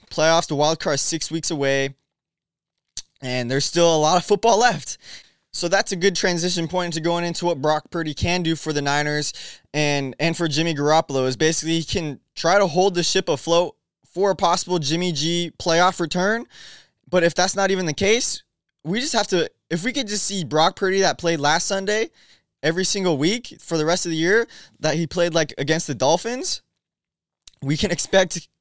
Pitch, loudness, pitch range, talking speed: 170 Hz, -21 LUFS, 155-185 Hz, 200 wpm